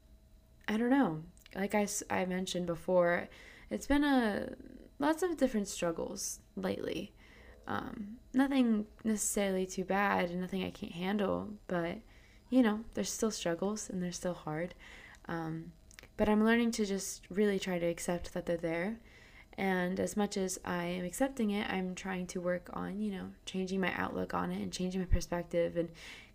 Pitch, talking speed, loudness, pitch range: 190 Hz, 170 wpm, -35 LUFS, 175-215 Hz